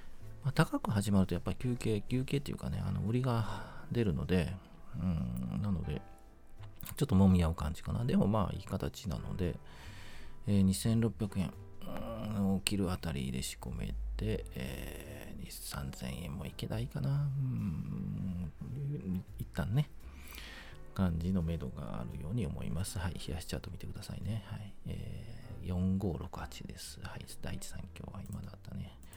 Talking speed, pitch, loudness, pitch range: 280 characters per minute, 100 Hz, -36 LUFS, 85-110 Hz